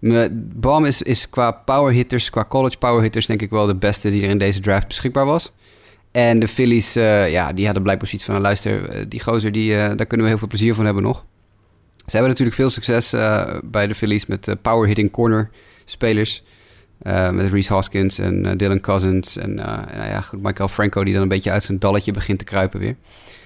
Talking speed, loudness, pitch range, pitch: 225 wpm, -18 LUFS, 100-115 Hz, 105 Hz